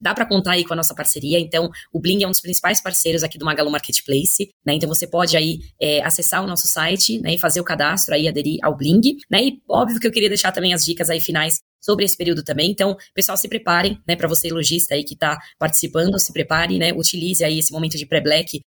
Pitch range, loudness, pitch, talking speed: 160-190 Hz, -18 LUFS, 170 Hz, 245 wpm